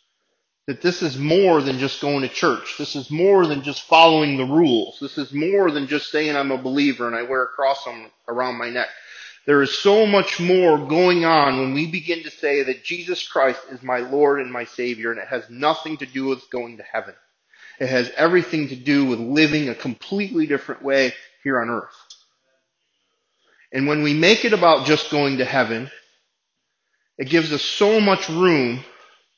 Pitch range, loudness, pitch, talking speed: 130-165 Hz, -19 LUFS, 145 Hz, 195 wpm